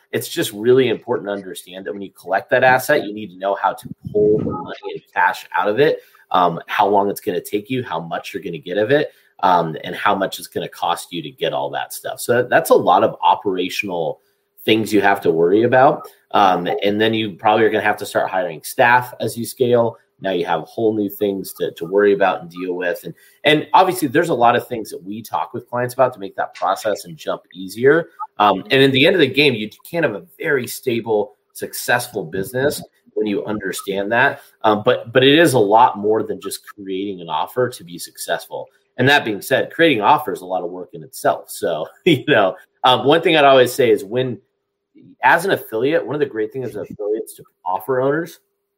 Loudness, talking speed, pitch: -18 LUFS, 230 wpm, 125 Hz